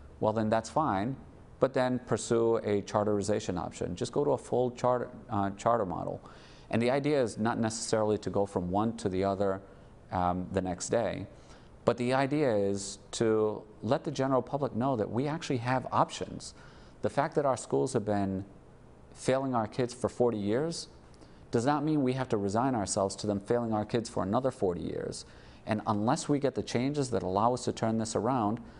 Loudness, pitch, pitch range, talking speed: -31 LUFS, 110 Hz, 100-125 Hz, 195 wpm